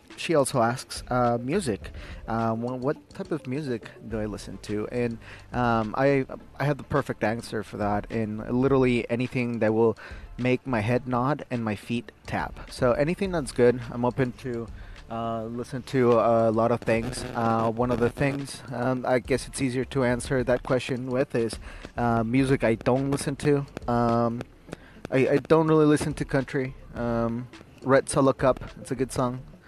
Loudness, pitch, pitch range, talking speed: -26 LUFS, 125 Hz, 115-135 Hz, 180 wpm